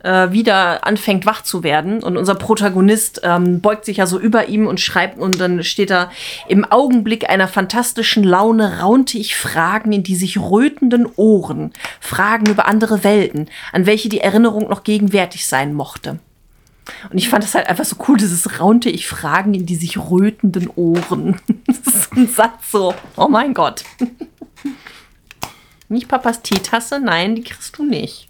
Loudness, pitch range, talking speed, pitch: -15 LUFS, 185-225 Hz, 165 wpm, 210 Hz